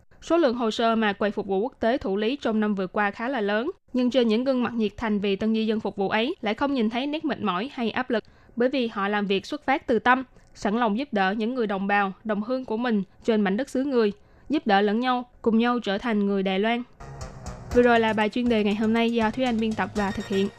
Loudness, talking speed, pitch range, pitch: -25 LUFS, 285 wpm, 205-245 Hz, 220 Hz